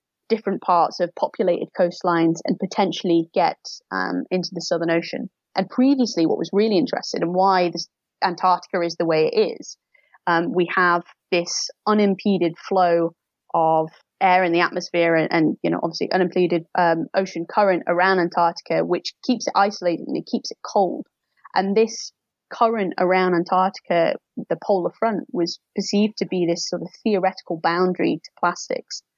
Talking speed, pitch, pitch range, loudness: 160 wpm, 180 Hz, 170-200 Hz, -21 LUFS